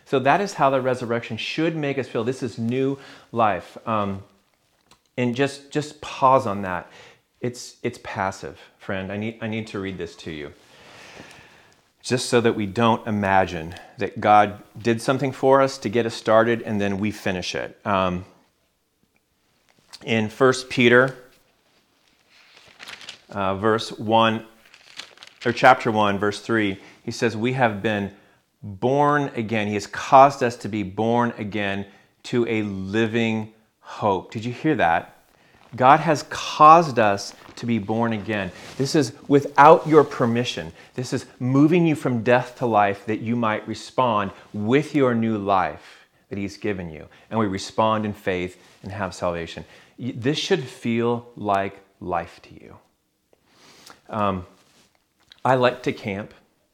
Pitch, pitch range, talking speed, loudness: 115 Hz, 100-125 Hz, 150 wpm, -22 LUFS